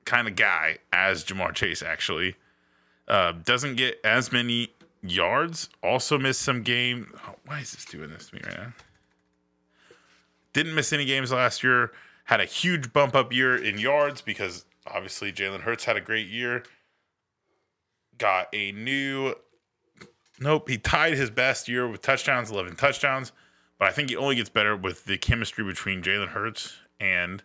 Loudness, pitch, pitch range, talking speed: -25 LUFS, 120 Hz, 100-135 Hz, 165 wpm